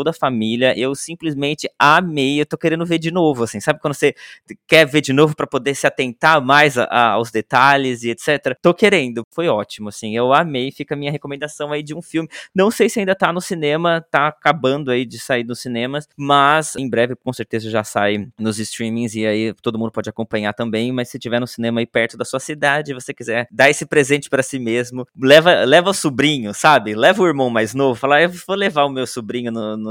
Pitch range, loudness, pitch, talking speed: 115-155 Hz, -17 LUFS, 135 Hz, 225 wpm